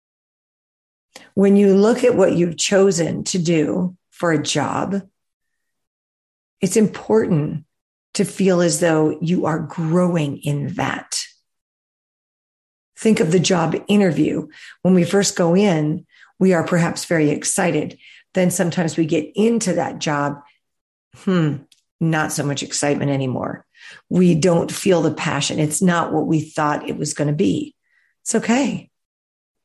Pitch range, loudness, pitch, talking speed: 150-190 Hz, -19 LUFS, 170 Hz, 140 wpm